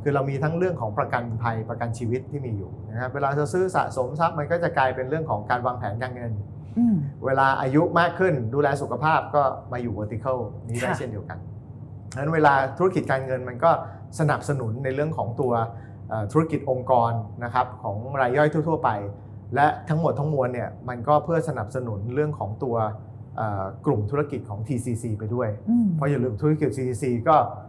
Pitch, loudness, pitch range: 130 Hz, -25 LUFS, 115-145 Hz